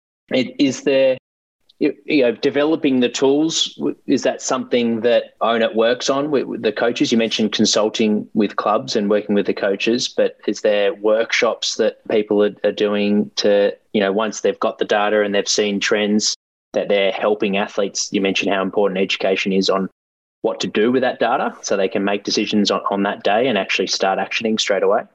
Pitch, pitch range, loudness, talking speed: 105 Hz, 100-135 Hz, -18 LUFS, 185 wpm